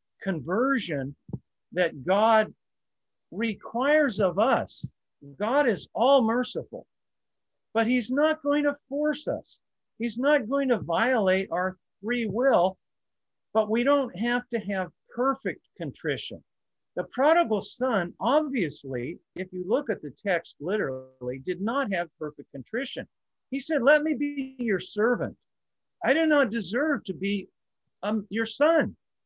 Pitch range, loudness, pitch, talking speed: 190-275 Hz, -27 LUFS, 230 Hz, 135 wpm